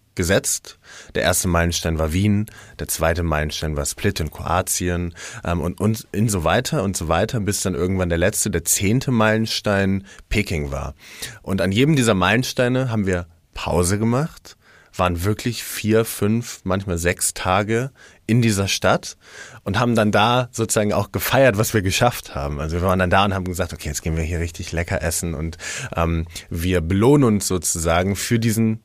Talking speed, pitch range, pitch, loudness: 180 wpm, 85-110 Hz, 95 Hz, -20 LUFS